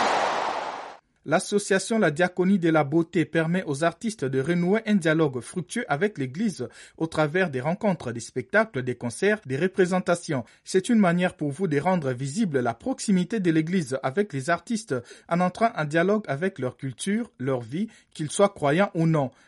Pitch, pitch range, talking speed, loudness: 170 Hz, 140-200 Hz, 170 wpm, -25 LUFS